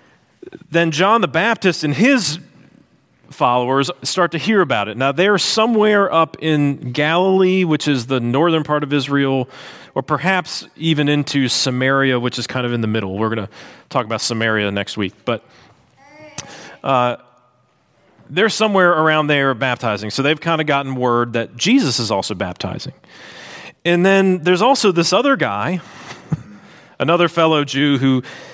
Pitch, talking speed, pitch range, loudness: 150 Hz, 155 wpm, 125-180 Hz, -17 LUFS